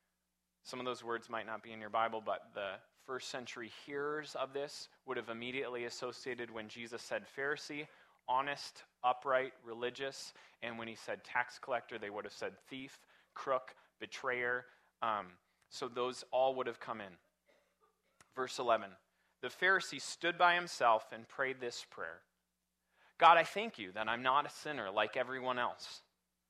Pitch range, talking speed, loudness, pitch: 115-140 Hz, 165 wpm, -38 LUFS, 125 Hz